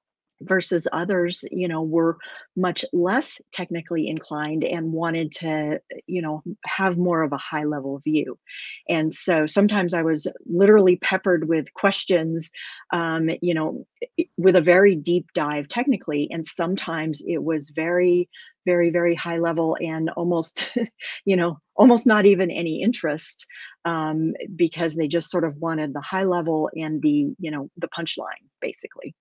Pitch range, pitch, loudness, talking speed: 160-185 Hz, 170 Hz, -22 LUFS, 150 wpm